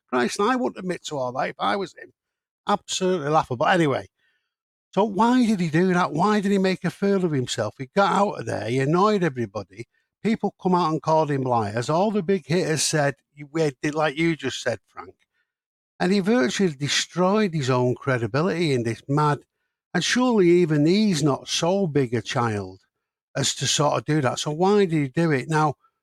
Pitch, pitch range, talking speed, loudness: 160 Hz, 135-195 Hz, 200 wpm, -22 LUFS